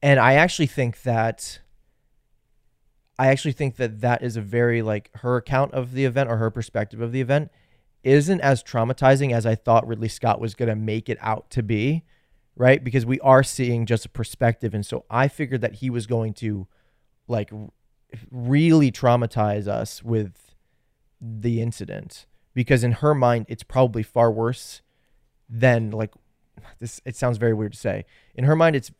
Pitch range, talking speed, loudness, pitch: 115-130 Hz, 180 wpm, -22 LUFS, 120 Hz